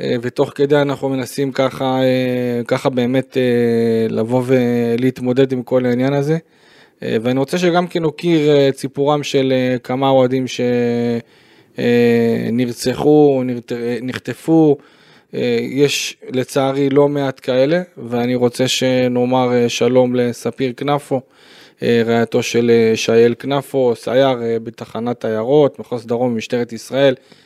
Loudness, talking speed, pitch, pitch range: -16 LUFS, 105 wpm, 130 Hz, 120-135 Hz